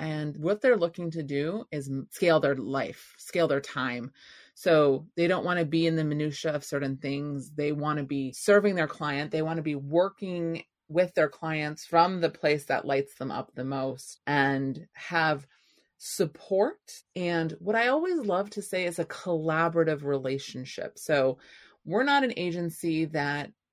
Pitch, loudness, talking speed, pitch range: 160 Hz, -28 LUFS, 175 wpm, 145-175 Hz